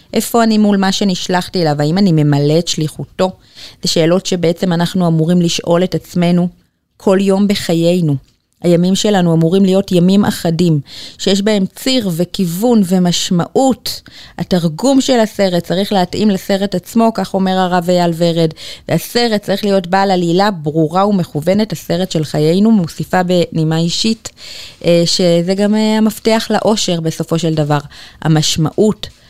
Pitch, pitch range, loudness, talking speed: 180 Hz, 165-200 Hz, -13 LUFS, 135 wpm